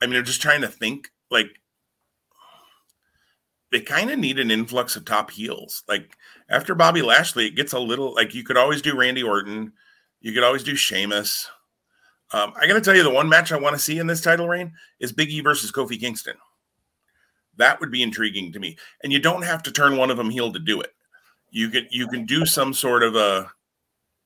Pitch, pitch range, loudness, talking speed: 125 Hz, 115-145 Hz, -20 LUFS, 220 wpm